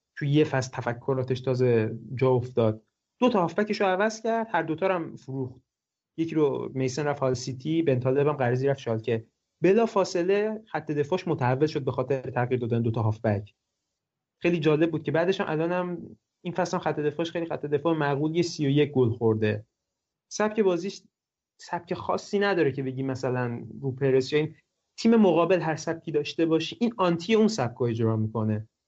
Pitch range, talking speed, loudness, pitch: 125-175 Hz, 185 wpm, -26 LUFS, 150 Hz